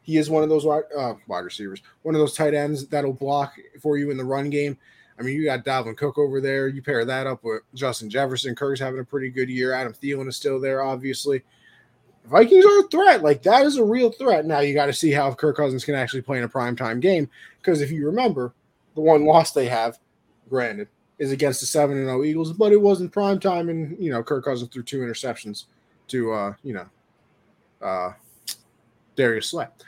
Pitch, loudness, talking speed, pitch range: 140 Hz, -21 LUFS, 220 wpm, 130-155 Hz